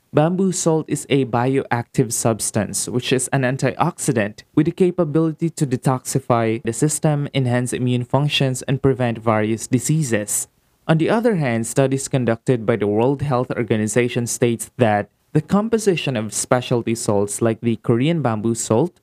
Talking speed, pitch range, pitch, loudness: 150 wpm, 115-150 Hz, 130 Hz, -19 LUFS